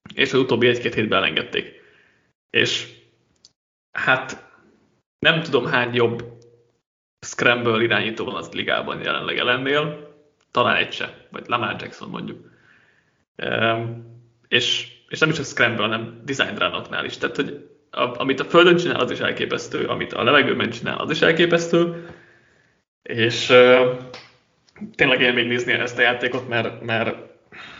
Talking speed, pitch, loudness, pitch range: 140 wpm, 120 Hz, -20 LUFS, 115-140 Hz